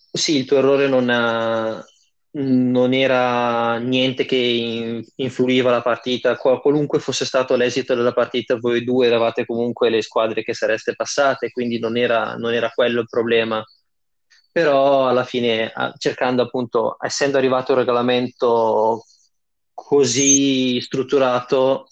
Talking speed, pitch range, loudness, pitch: 135 wpm, 115-130 Hz, -18 LUFS, 125 Hz